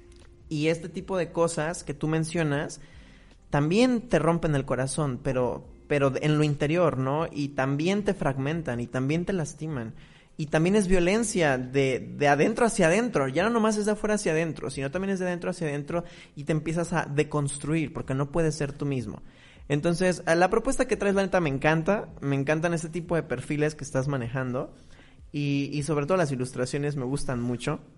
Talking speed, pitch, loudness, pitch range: 190 wpm, 155 Hz, -27 LUFS, 140-175 Hz